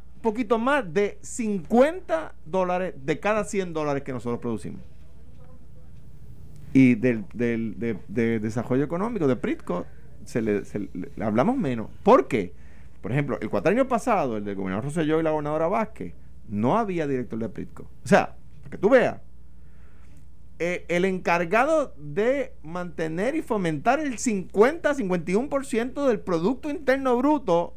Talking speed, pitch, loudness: 150 wpm, 165 Hz, -25 LUFS